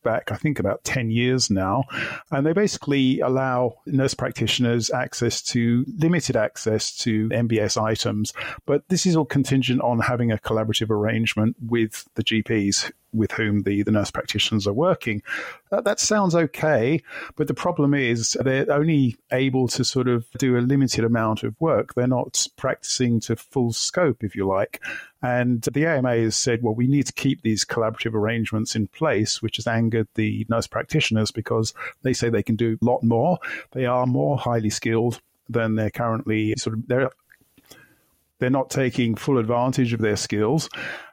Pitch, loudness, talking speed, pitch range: 120 Hz, -22 LUFS, 175 wpm, 110-130 Hz